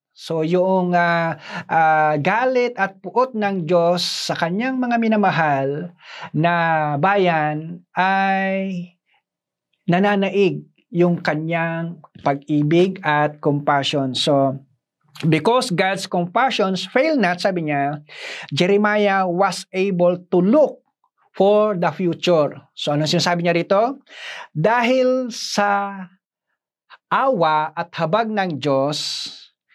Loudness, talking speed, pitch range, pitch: -19 LUFS, 100 wpm, 160-200 Hz, 180 Hz